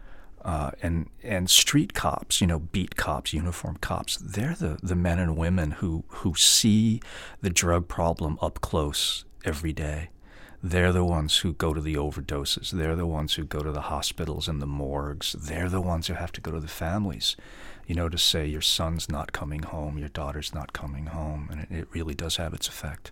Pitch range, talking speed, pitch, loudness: 75-90 Hz, 200 wpm, 80 Hz, -27 LUFS